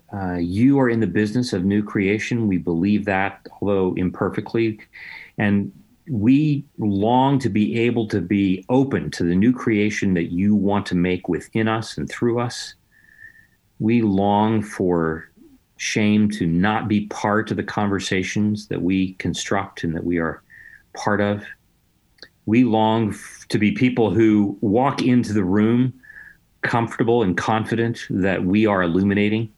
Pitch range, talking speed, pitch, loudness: 95-115 Hz, 150 wpm, 105 Hz, -20 LUFS